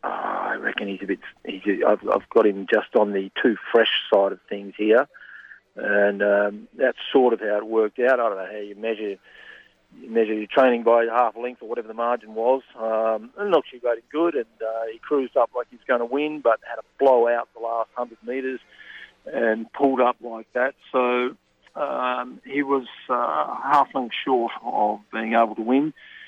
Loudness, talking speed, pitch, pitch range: -23 LUFS, 210 wpm, 115 Hz, 105-125 Hz